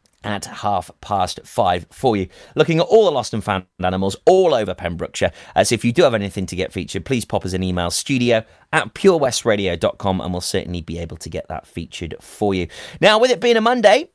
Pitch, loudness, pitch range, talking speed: 105 Hz, -19 LUFS, 95-155 Hz, 220 wpm